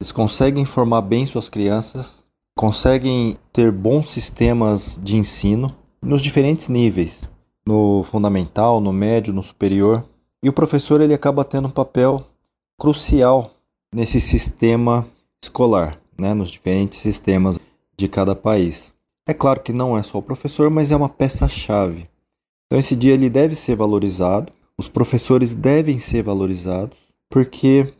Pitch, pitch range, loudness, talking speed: 115 Hz, 100-135 Hz, -18 LUFS, 140 wpm